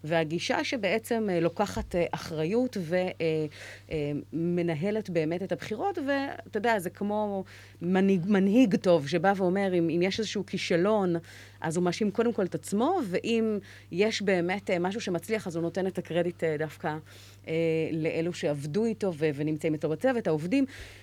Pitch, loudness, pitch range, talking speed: 180 Hz, -29 LUFS, 165-210 Hz, 135 wpm